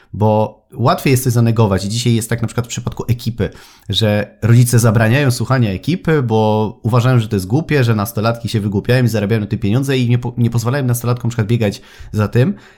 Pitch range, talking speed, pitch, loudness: 110-125 Hz, 205 wpm, 115 Hz, -15 LUFS